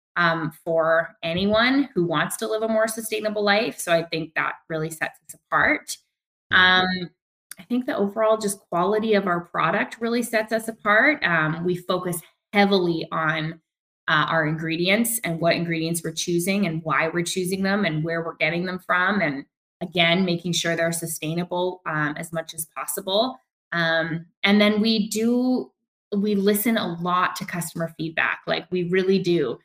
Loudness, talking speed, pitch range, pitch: -22 LUFS, 170 wpm, 165-205 Hz, 180 Hz